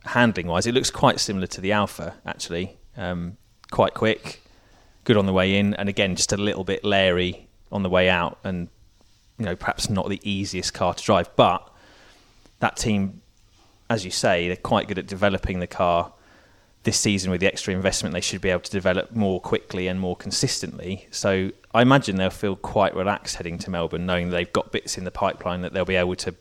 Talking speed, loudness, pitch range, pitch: 205 wpm, -23 LUFS, 90-100 Hz, 95 Hz